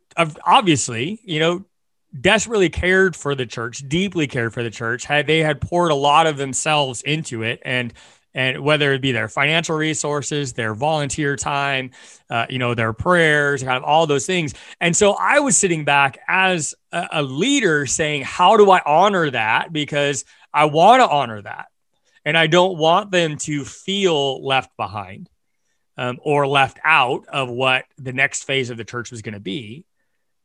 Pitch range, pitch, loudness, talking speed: 130-165 Hz, 145 Hz, -18 LUFS, 175 wpm